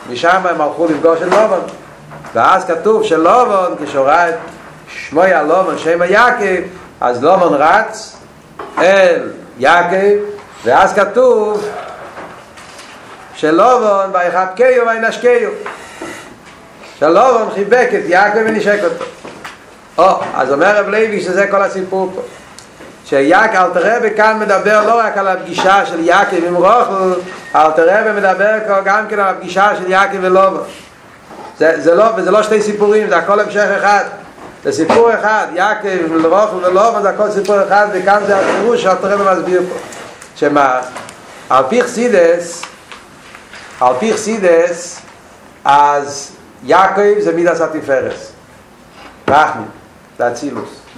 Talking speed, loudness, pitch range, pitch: 130 wpm, -12 LUFS, 175-215 Hz, 195 Hz